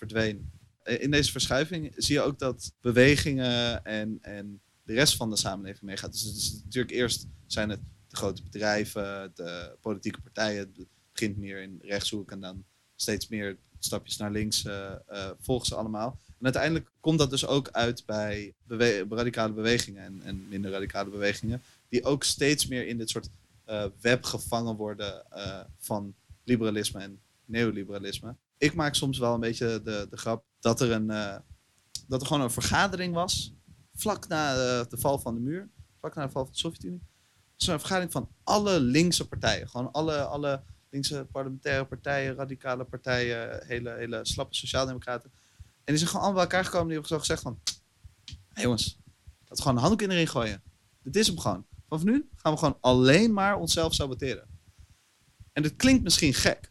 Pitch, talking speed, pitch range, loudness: 115 Hz, 185 wpm, 100-135 Hz, -29 LUFS